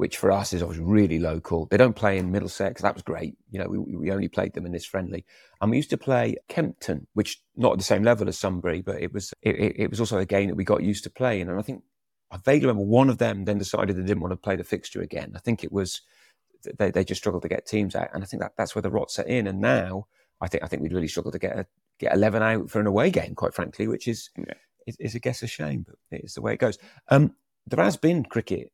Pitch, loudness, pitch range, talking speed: 100 Hz, -26 LUFS, 90-110 Hz, 280 wpm